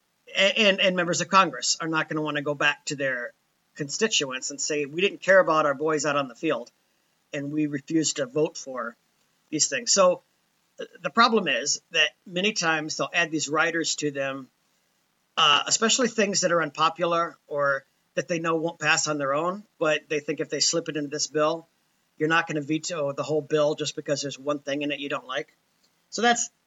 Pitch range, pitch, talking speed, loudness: 150-175 Hz, 155 Hz, 215 wpm, -24 LUFS